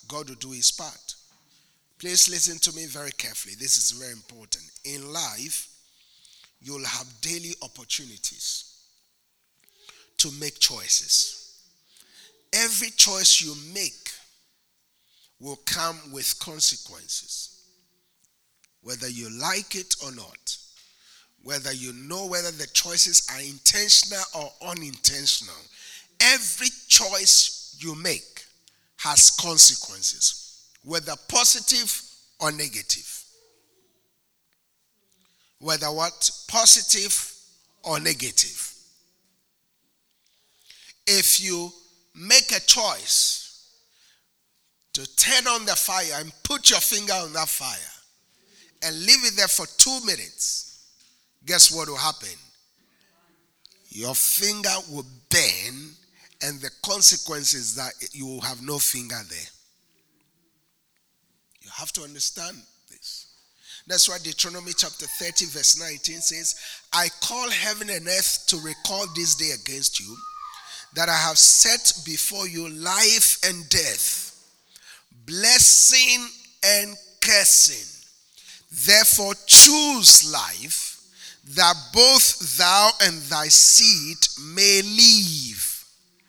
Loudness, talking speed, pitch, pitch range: -17 LUFS, 105 wpm, 170 Hz, 140-200 Hz